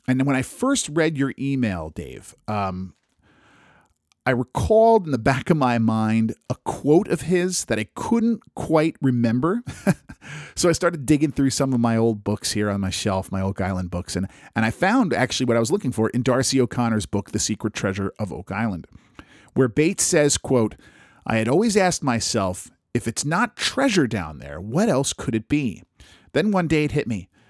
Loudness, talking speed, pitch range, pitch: -22 LUFS, 195 wpm, 105-155 Hz, 125 Hz